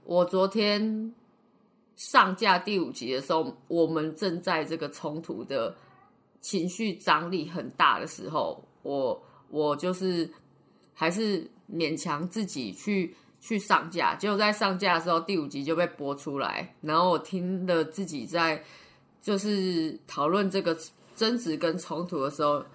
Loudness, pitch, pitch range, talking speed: -28 LUFS, 180 Hz, 160-205 Hz, 210 characters per minute